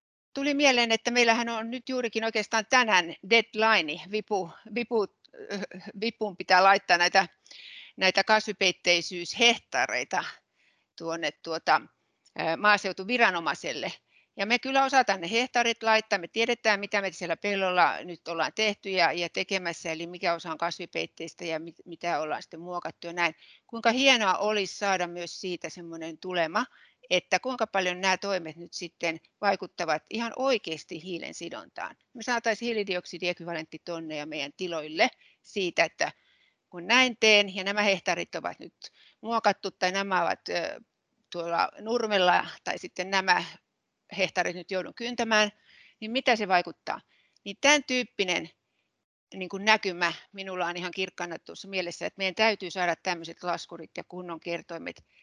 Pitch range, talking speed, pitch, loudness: 175-220 Hz, 140 wpm, 190 Hz, -27 LUFS